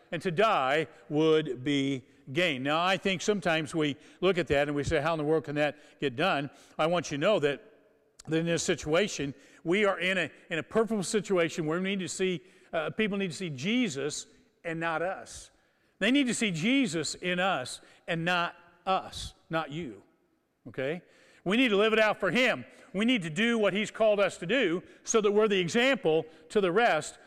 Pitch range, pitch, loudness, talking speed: 155-205 Hz, 175 Hz, -29 LUFS, 210 wpm